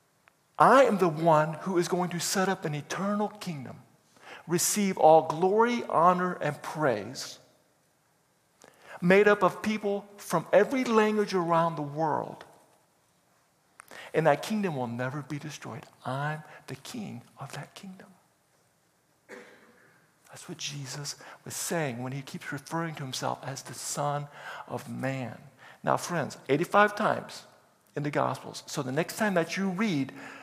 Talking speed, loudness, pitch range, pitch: 140 wpm, -28 LUFS, 145-195 Hz, 165 Hz